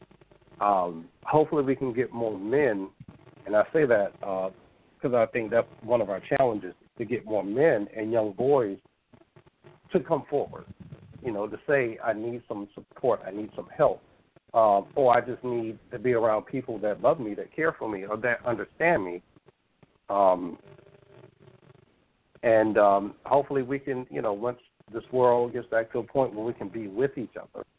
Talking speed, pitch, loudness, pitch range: 185 wpm, 120 Hz, -27 LUFS, 105-130 Hz